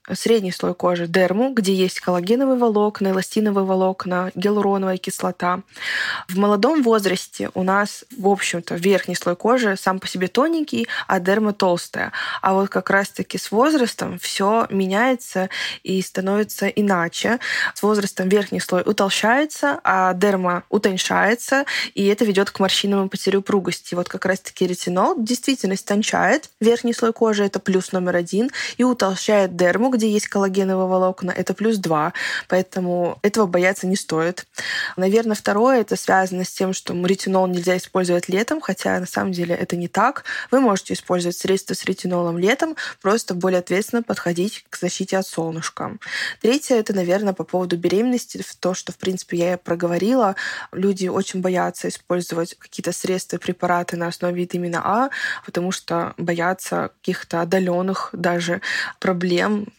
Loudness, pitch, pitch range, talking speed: -20 LUFS, 190 Hz, 180-210 Hz, 150 wpm